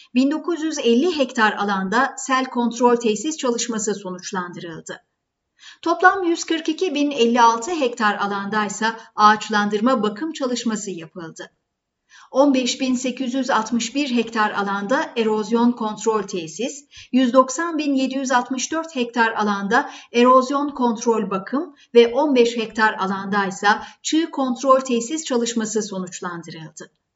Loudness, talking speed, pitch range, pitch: -20 LUFS, 85 wpm, 210-270 Hz, 235 Hz